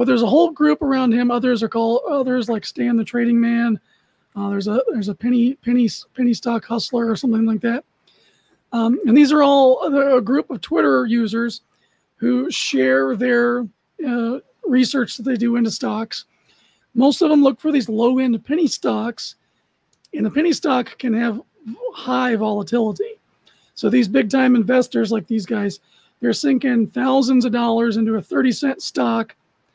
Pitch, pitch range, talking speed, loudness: 240 Hz, 225-265 Hz, 175 wpm, -18 LUFS